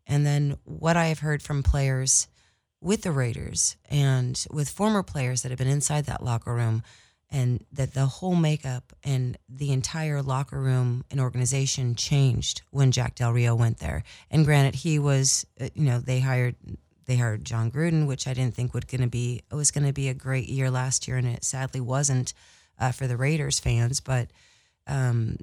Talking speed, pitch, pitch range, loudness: 190 wpm, 130 Hz, 125-140 Hz, -26 LUFS